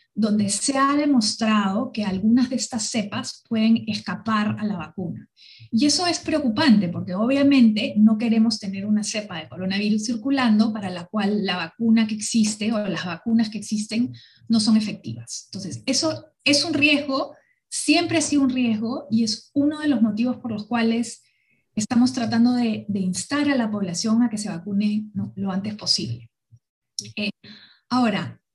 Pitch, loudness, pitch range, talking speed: 220 Hz, -22 LUFS, 205-250 Hz, 165 wpm